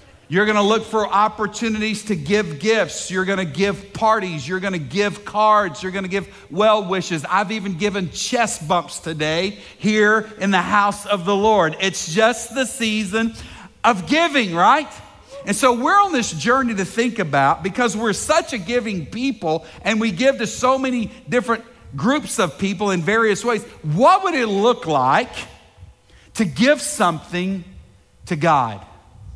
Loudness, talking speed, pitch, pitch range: -19 LUFS, 160 wpm, 205 Hz, 175-225 Hz